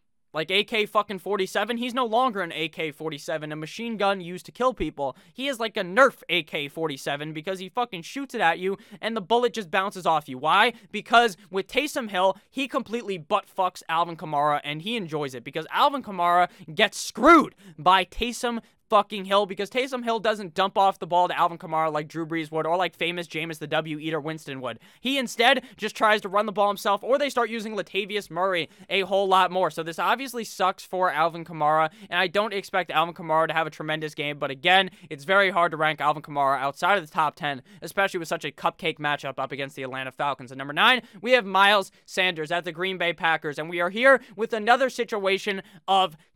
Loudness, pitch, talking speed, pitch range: -24 LUFS, 185 Hz, 215 wpm, 160-210 Hz